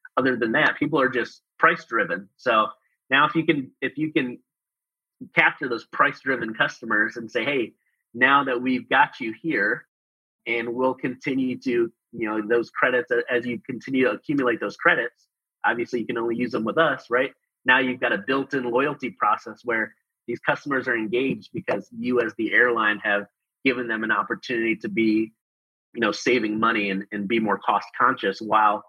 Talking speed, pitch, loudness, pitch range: 185 wpm, 120 Hz, -23 LUFS, 110-130 Hz